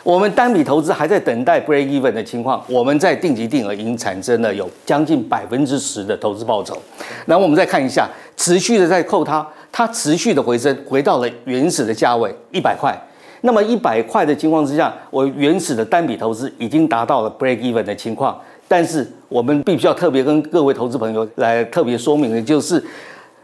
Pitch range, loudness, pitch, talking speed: 120-160 Hz, -17 LUFS, 140 Hz, 345 characters per minute